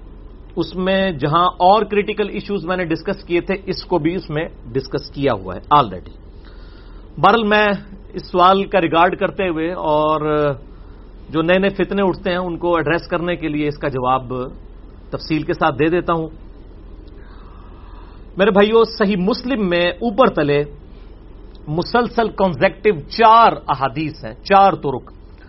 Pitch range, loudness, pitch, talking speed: 135-195 Hz, -17 LUFS, 170 Hz, 155 wpm